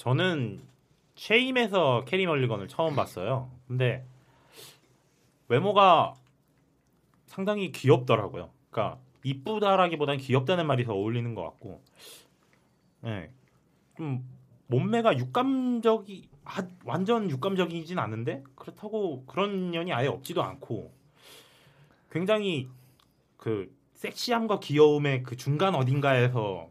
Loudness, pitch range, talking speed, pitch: -27 LUFS, 130-190 Hz, 250 characters per minute, 145 Hz